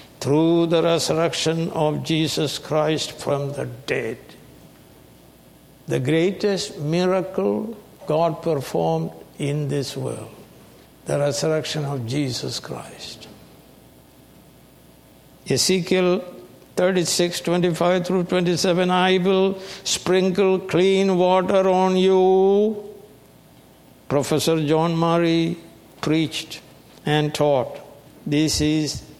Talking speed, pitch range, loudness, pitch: 85 wpm, 150-185 Hz, -21 LUFS, 165 Hz